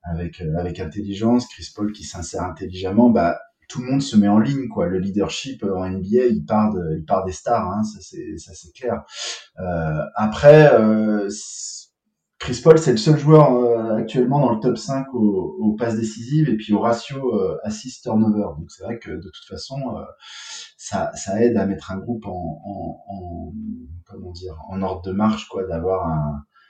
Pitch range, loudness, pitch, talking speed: 95-120 Hz, -20 LUFS, 105 Hz, 195 wpm